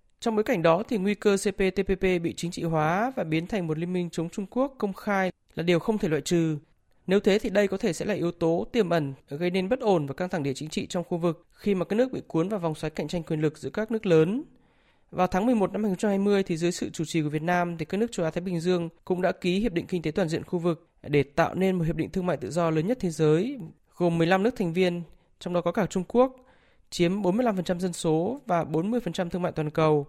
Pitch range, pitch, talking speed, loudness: 165-200 Hz, 180 Hz, 275 wpm, -27 LUFS